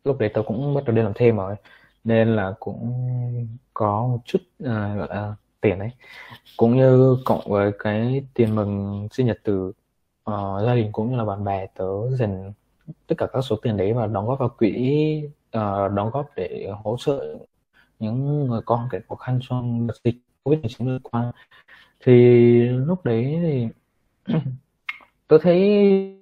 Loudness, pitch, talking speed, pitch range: -22 LUFS, 120 Hz, 175 wpm, 105-130 Hz